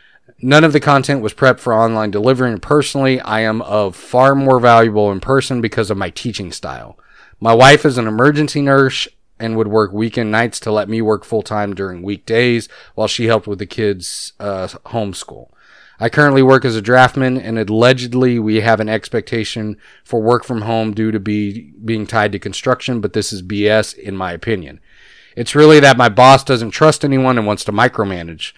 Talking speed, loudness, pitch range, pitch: 195 wpm, -14 LUFS, 105-130 Hz, 115 Hz